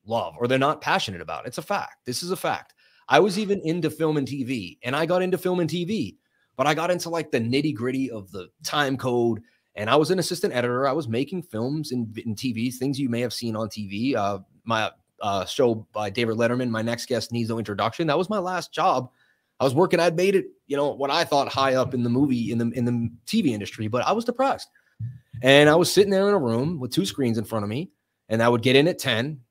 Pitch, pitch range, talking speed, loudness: 135 Hz, 115-165 Hz, 255 wpm, -24 LUFS